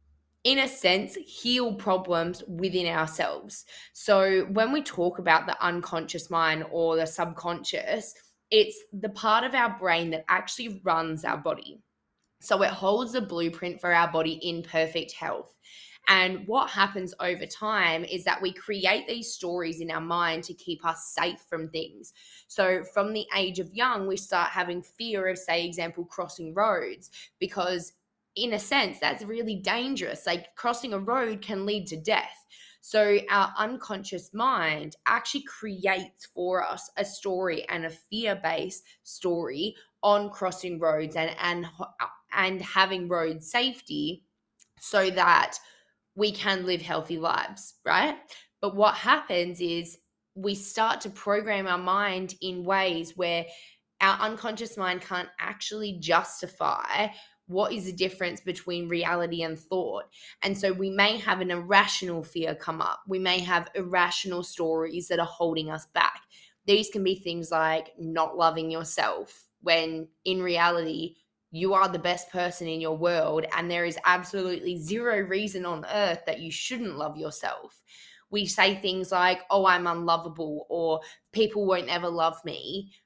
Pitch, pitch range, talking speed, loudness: 185 Hz, 170-205 Hz, 155 wpm, -27 LUFS